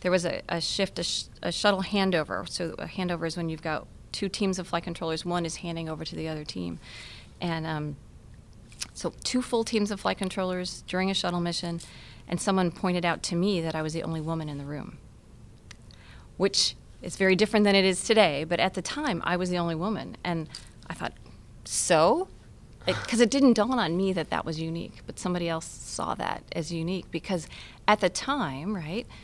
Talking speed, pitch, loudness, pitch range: 210 wpm, 175 Hz, -28 LUFS, 160-195 Hz